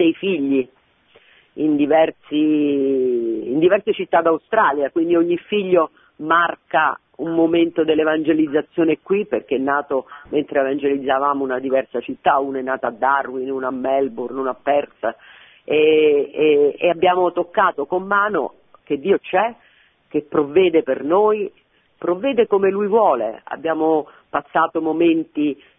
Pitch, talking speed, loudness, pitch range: 160 Hz, 130 wpm, -19 LUFS, 140-195 Hz